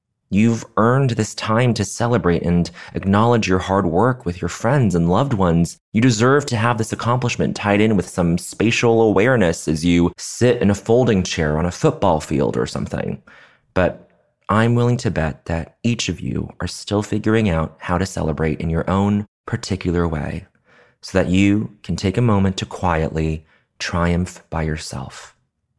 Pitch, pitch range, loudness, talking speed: 95 Hz, 85-115 Hz, -19 LUFS, 175 wpm